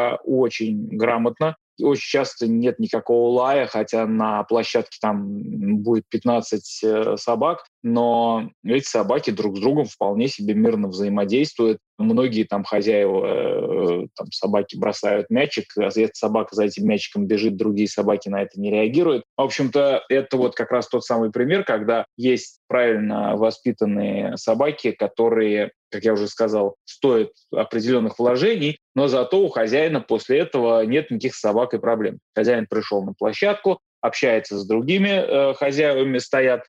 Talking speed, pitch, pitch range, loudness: 140 wpm, 115 Hz, 110-135 Hz, -21 LUFS